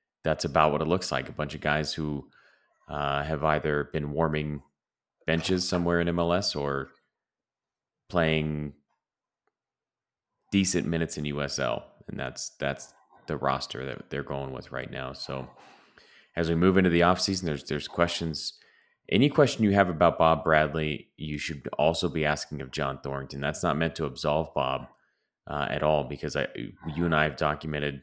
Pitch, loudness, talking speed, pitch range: 75 Hz, -28 LUFS, 165 wpm, 75-85 Hz